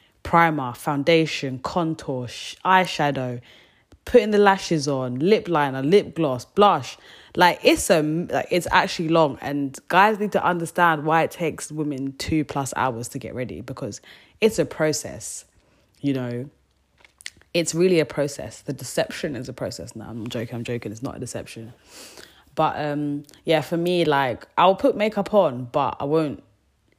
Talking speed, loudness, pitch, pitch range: 160 wpm, -22 LUFS, 145 Hz, 125-170 Hz